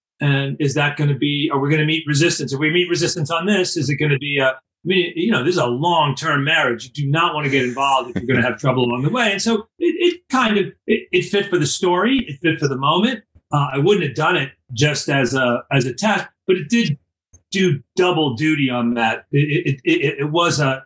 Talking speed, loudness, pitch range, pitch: 270 wpm, -18 LUFS, 135-180 Hz, 150 Hz